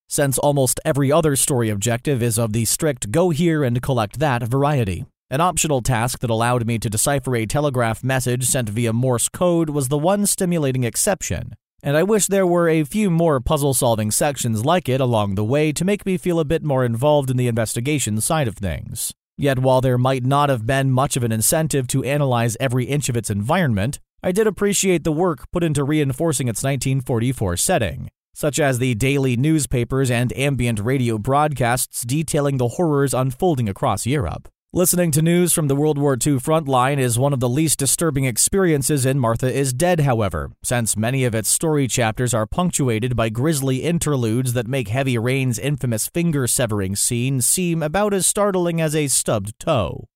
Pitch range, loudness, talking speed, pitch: 120-155 Hz, -19 LUFS, 190 wpm, 135 Hz